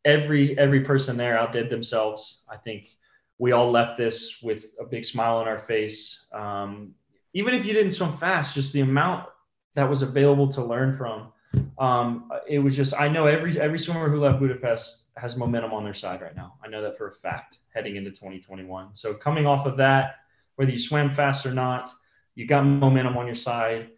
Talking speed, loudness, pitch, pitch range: 200 wpm, -24 LUFS, 125 Hz, 115-140 Hz